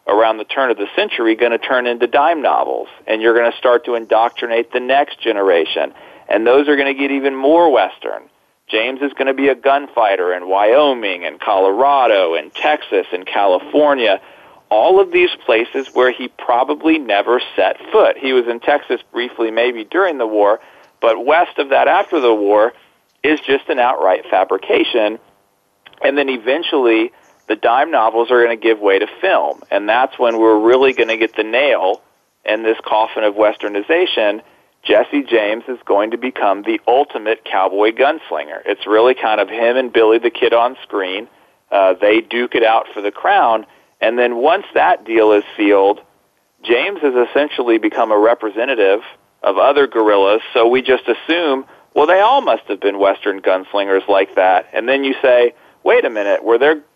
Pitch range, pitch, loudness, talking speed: 110-140 Hz, 120 Hz, -15 LUFS, 180 wpm